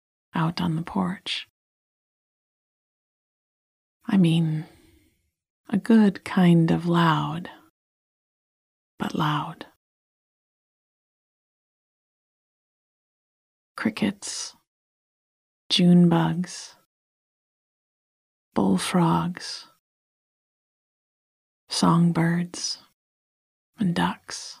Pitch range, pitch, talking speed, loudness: 165-185 Hz, 170 Hz, 50 wpm, -23 LUFS